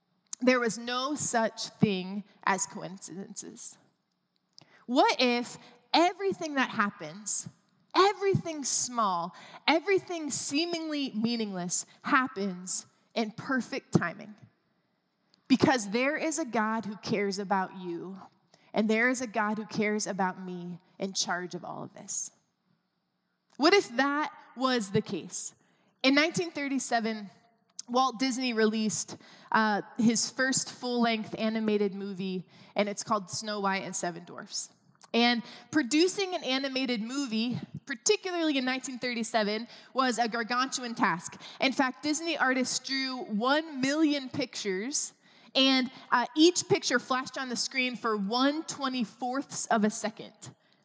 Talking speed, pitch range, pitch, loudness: 125 wpm, 205-265 Hz, 235 Hz, -29 LUFS